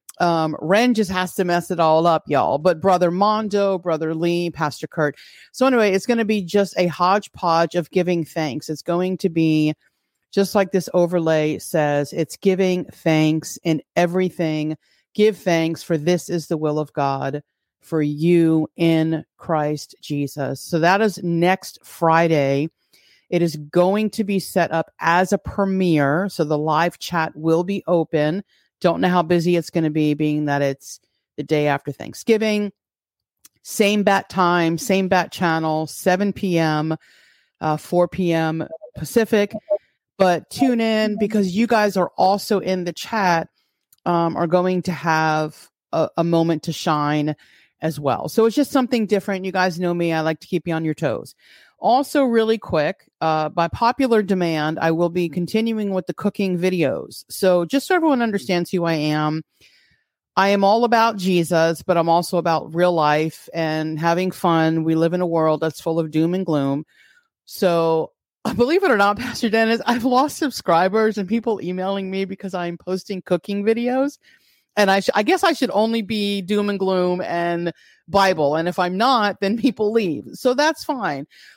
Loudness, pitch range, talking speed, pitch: -20 LUFS, 160-200 Hz, 175 wpm, 175 Hz